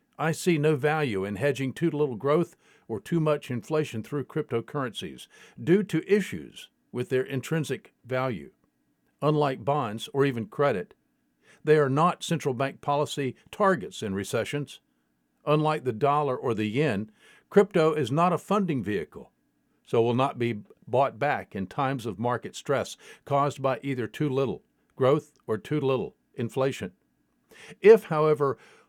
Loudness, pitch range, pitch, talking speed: -27 LUFS, 125-155 Hz, 140 Hz, 145 wpm